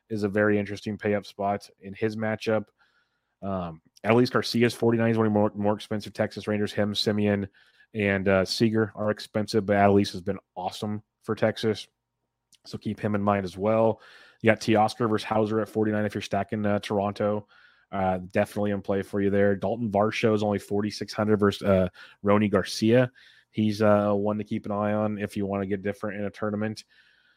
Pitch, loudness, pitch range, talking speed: 105 Hz, -26 LUFS, 100-110 Hz, 195 wpm